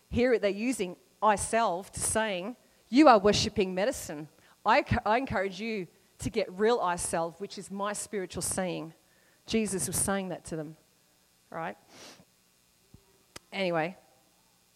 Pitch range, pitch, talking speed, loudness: 160-210 Hz, 190 Hz, 140 wpm, -29 LUFS